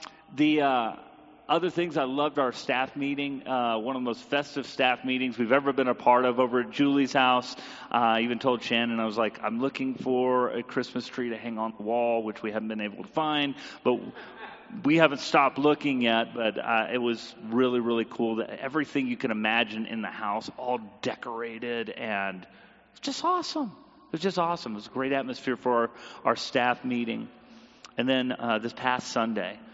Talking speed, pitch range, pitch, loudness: 200 wpm, 115-135 Hz, 125 Hz, -28 LUFS